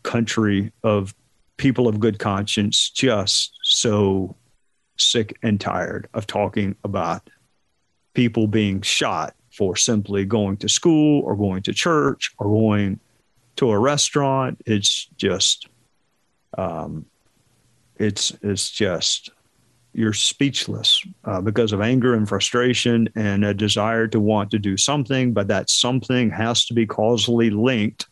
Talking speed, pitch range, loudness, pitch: 130 wpm, 105-120 Hz, -20 LUFS, 110 Hz